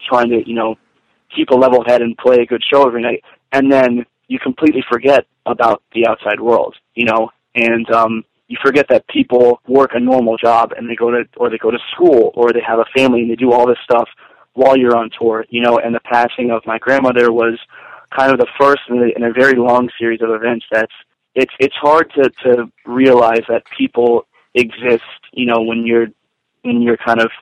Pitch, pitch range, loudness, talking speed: 120 Hz, 115-130 Hz, -13 LUFS, 215 wpm